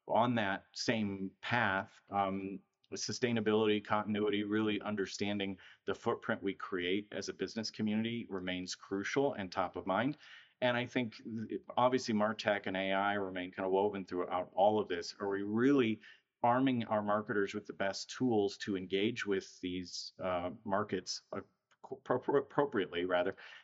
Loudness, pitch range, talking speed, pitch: -35 LUFS, 95-110 Hz, 145 wpm, 100 Hz